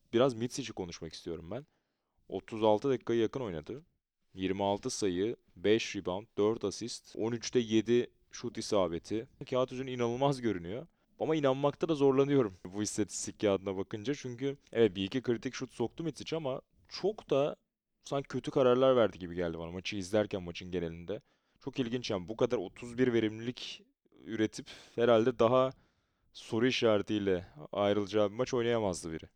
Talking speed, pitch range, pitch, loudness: 145 wpm, 100-130 Hz, 115 Hz, -33 LUFS